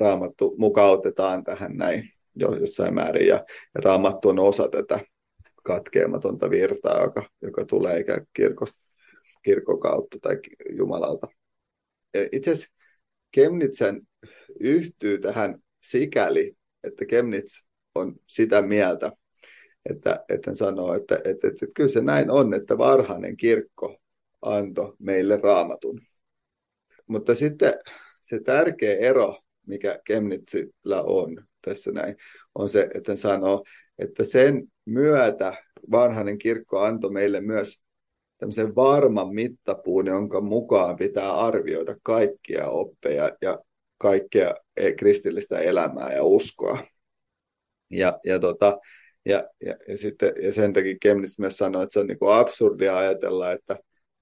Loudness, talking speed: -23 LUFS, 120 wpm